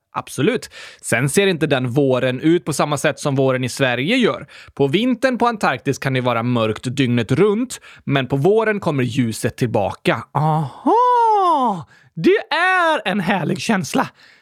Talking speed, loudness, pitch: 155 wpm, -18 LUFS, 155 Hz